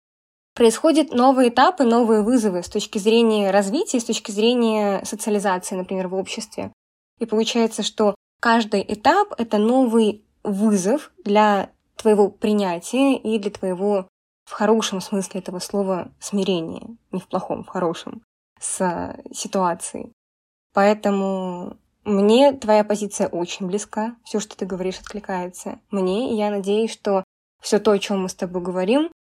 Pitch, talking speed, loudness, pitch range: 210 Hz, 140 wpm, -21 LUFS, 195-230 Hz